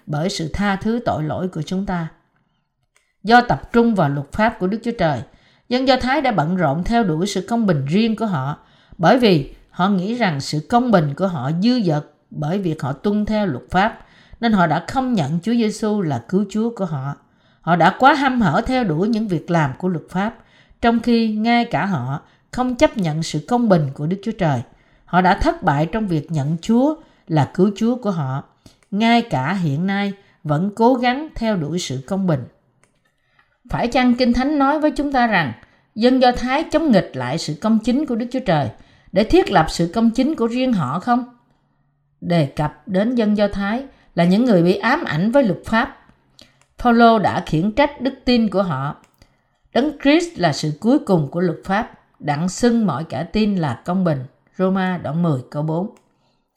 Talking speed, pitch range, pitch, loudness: 205 wpm, 160-235 Hz, 190 Hz, -19 LUFS